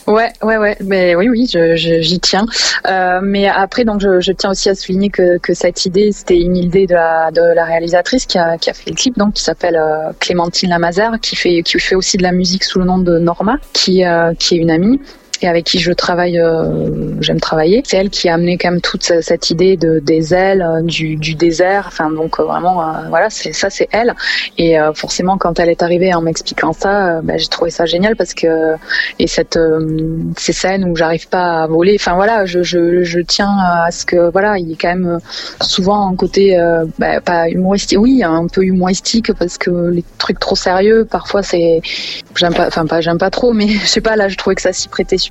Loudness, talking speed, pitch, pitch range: -13 LUFS, 235 wpm, 180 Hz, 170-195 Hz